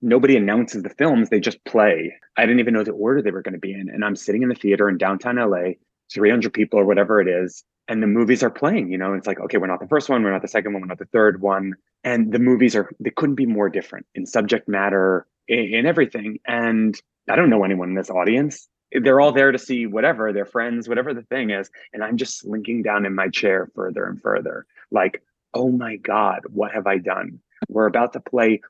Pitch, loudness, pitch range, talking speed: 110 Hz, -20 LUFS, 95-120 Hz, 245 wpm